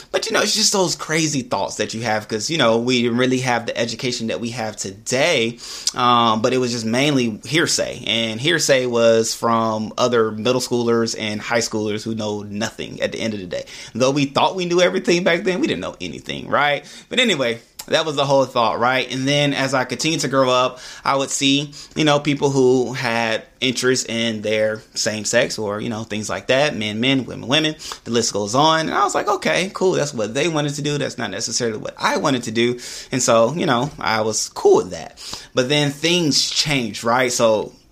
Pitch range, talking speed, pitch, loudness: 115-140 Hz, 225 wpm, 125 Hz, -19 LUFS